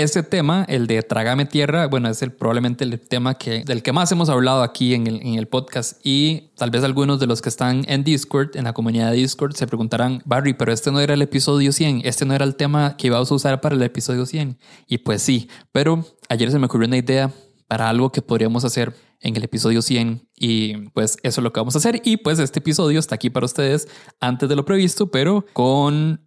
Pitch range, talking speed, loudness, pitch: 120-145 Hz, 240 wpm, -19 LUFS, 130 Hz